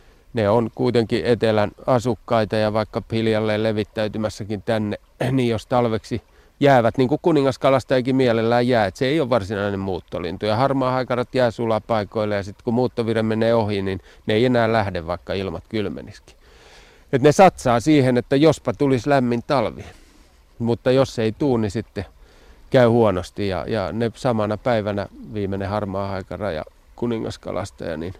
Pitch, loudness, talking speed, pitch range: 115 Hz, -21 LUFS, 150 wpm, 105-125 Hz